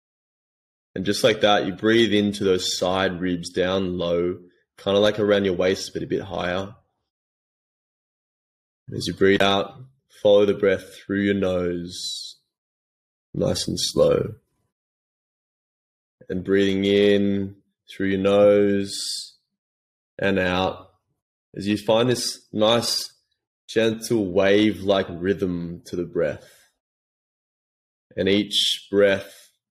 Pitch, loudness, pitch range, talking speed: 100 Hz, -22 LUFS, 90-105 Hz, 120 wpm